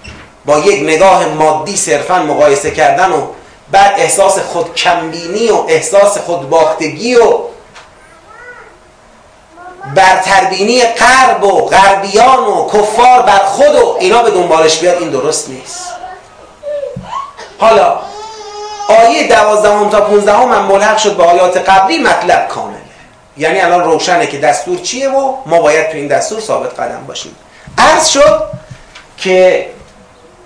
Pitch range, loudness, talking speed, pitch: 175-275 Hz, -9 LUFS, 130 wpm, 200 Hz